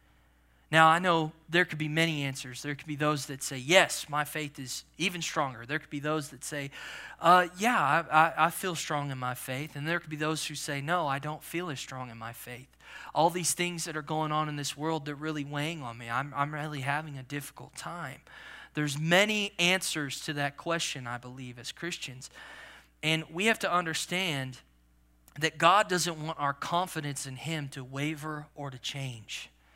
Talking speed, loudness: 205 wpm, -30 LUFS